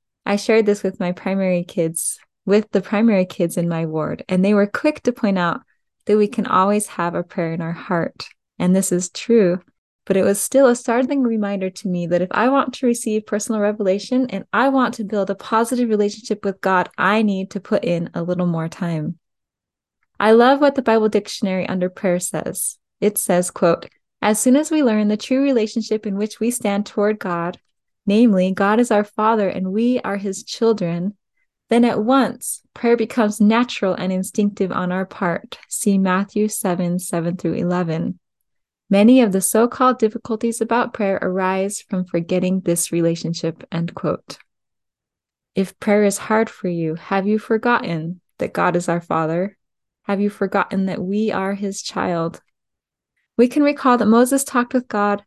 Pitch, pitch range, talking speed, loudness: 200 Hz, 180-225 Hz, 185 wpm, -19 LUFS